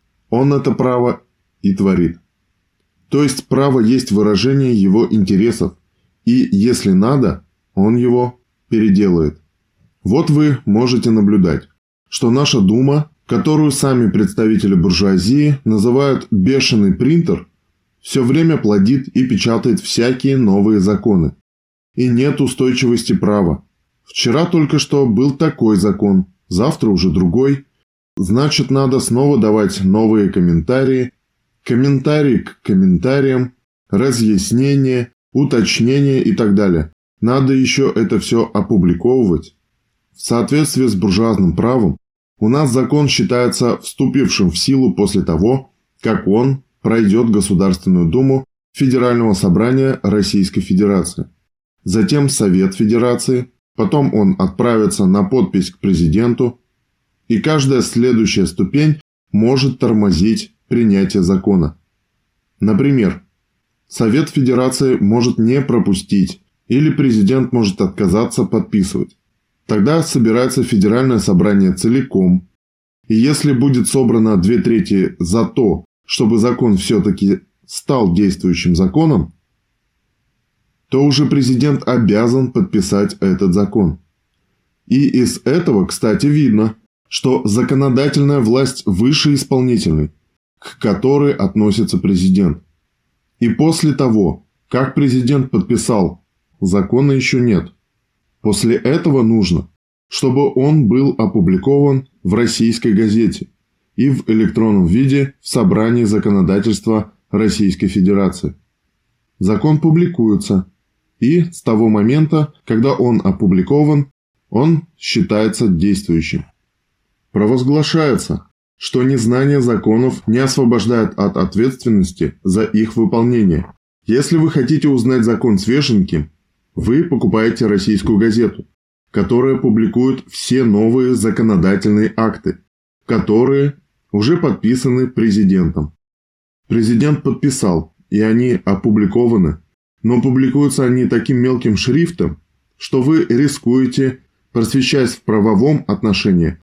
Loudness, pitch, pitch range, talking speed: -14 LUFS, 120 Hz, 105-135 Hz, 105 wpm